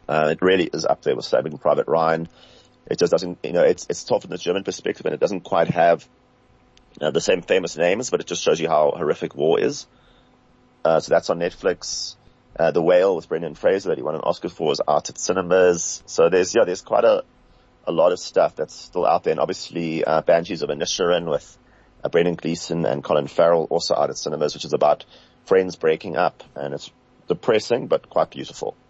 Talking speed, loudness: 220 wpm, -21 LUFS